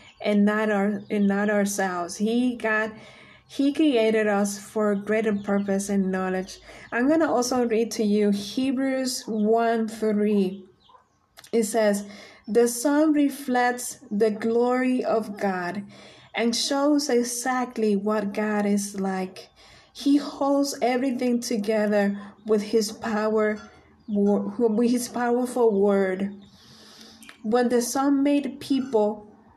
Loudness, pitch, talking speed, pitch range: -24 LUFS, 220 Hz, 120 wpm, 205-245 Hz